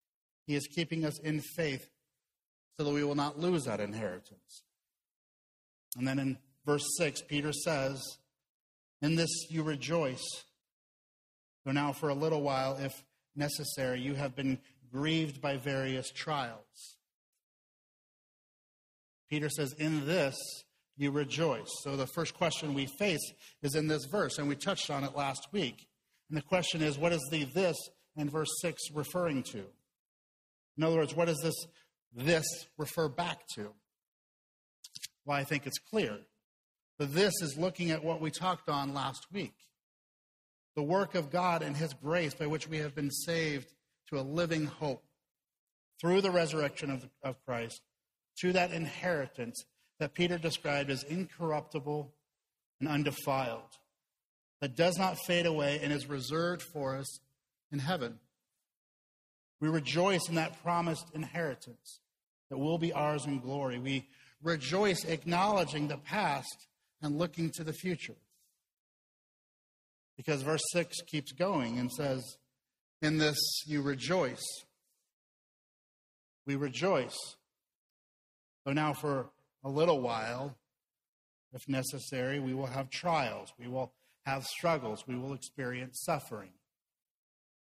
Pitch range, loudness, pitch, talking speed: 135-165 Hz, -34 LUFS, 150 Hz, 140 wpm